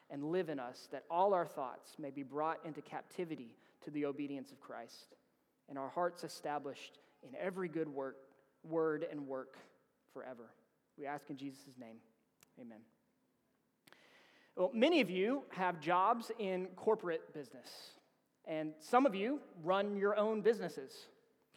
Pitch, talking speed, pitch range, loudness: 160 Hz, 145 wpm, 140-185 Hz, -38 LUFS